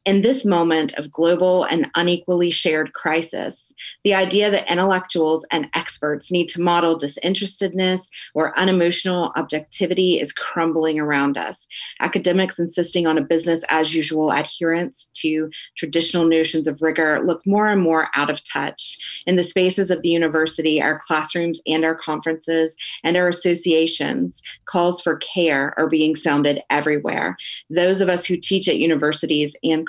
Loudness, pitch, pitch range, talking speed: -20 LUFS, 165 Hz, 155-180 Hz, 150 wpm